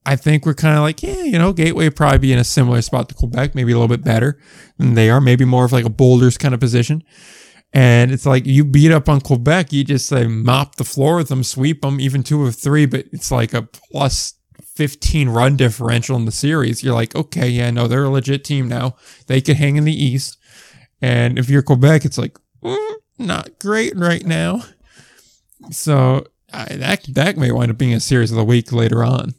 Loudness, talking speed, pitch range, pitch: -15 LUFS, 230 wpm, 125-150 Hz, 135 Hz